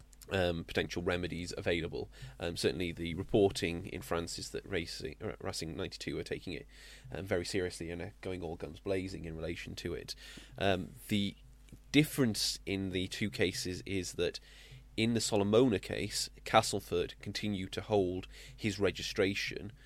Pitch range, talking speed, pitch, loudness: 85-110 Hz, 150 wpm, 95 Hz, -35 LUFS